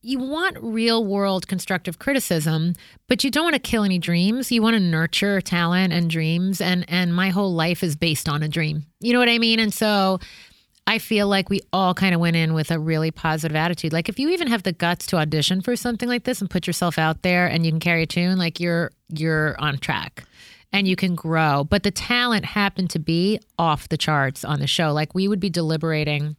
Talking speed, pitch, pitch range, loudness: 230 wpm, 180 Hz, 160-205 Hz, -21 LUFS